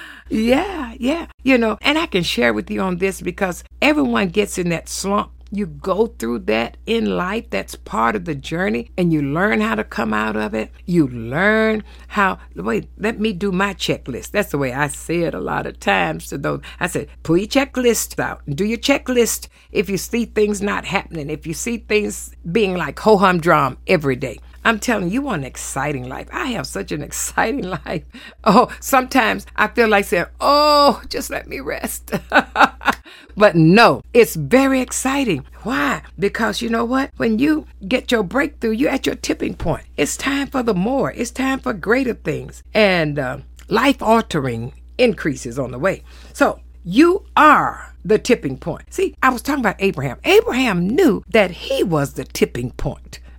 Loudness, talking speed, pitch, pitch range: -18 LUFS, 190 wpm, 210 Hz, 160-245 Hz